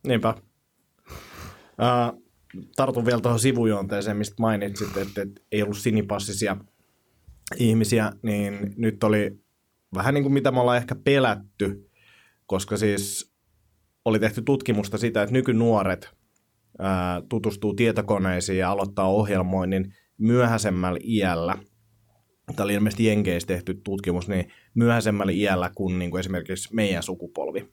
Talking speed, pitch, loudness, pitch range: 115 wpm, 105 Hz, -24 LUFS, 95-115 Hz